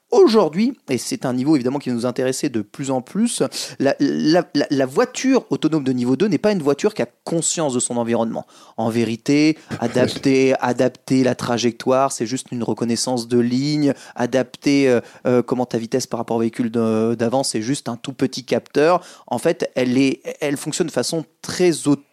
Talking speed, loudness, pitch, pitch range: 190 wpm, -20 LUFS, 130 Hz, 120-150 Hz